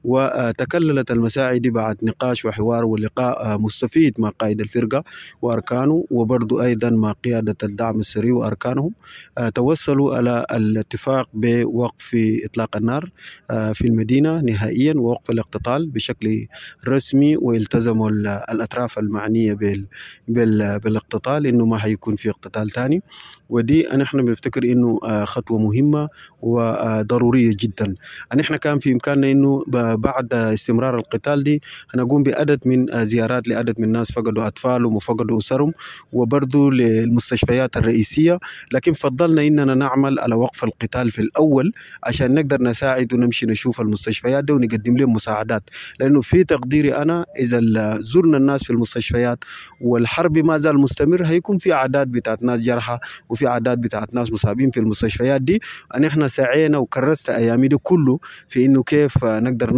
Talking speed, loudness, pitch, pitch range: 135 wpm, -19 LUFS, 120 Hz, 115-135 Hz